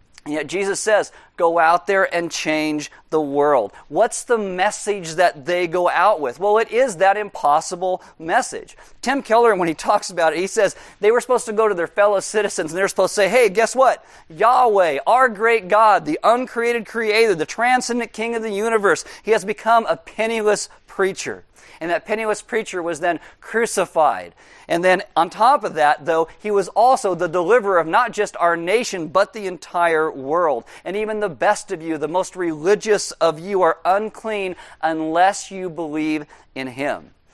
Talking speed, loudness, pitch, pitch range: 185 wpm, -19 LUFS, 195 Hz, 170-220 Hz